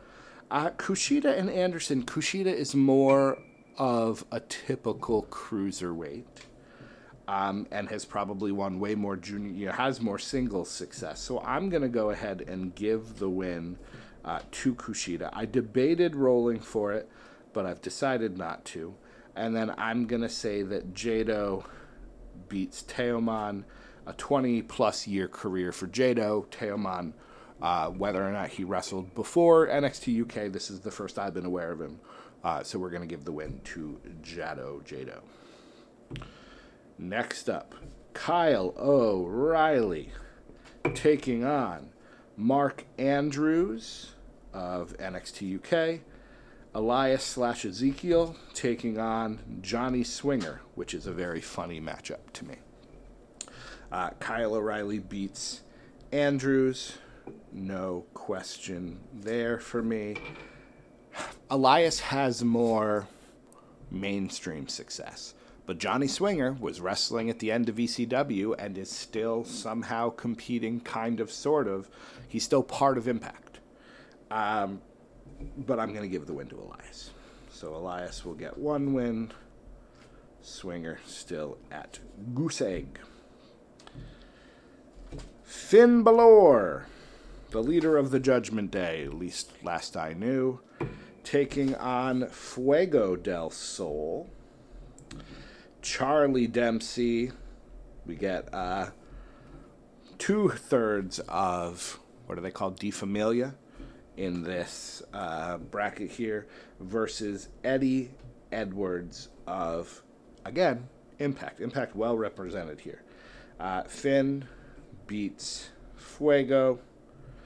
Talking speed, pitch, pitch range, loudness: 120 wpm, 115 Hz, 100-135 Hz, -29 LUFS